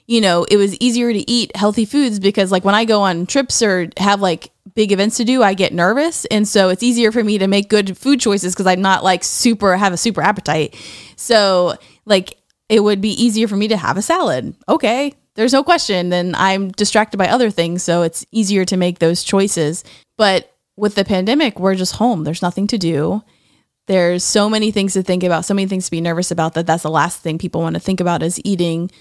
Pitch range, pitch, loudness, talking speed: 180-220 Hz, 195 Hz, -15 LUFS, 230 wpm